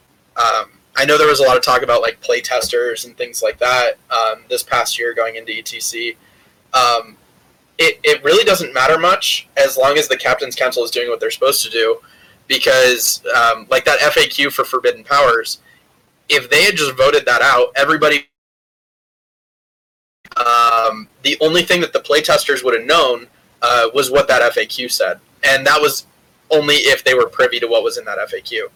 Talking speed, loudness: 190 wpm, -14 LUFS